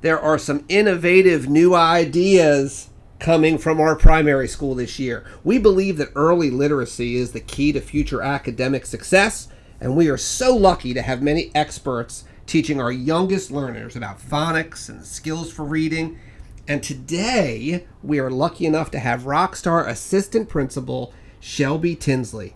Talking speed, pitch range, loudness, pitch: 155 wpm, 125-165 Hz, -19 LUFS, 145 Hz